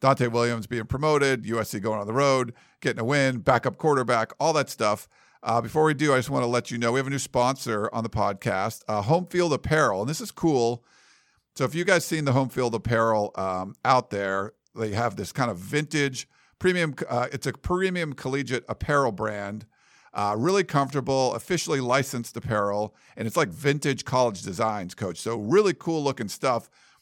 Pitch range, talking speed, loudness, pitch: 110-140 Hz, 195 wpm, -25 LUFS, 125 Hz